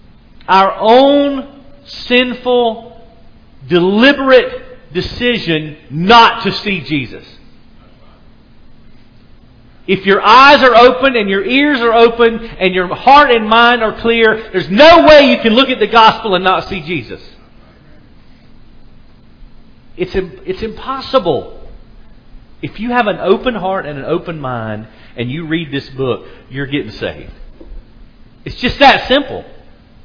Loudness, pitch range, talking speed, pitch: -10 LUFS, 150-245 Hz, 130 wpm, 195 Hz